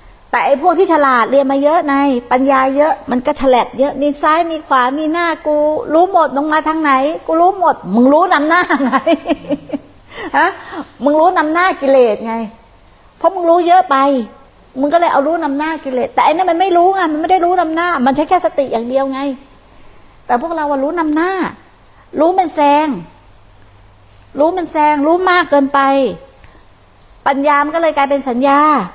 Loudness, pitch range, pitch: -13 LUFS, 270-330 Hz, 295 Hz